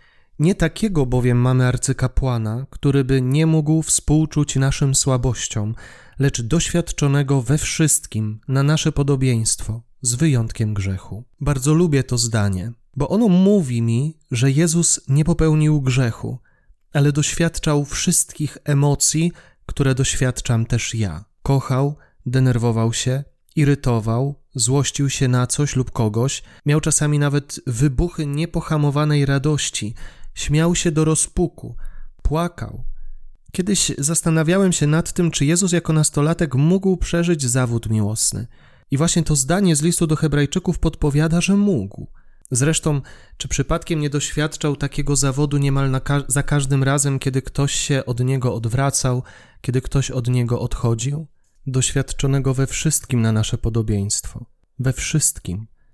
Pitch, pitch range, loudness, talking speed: 140 Hz, 125-155 Hz, -19 LUFS, 130 wpm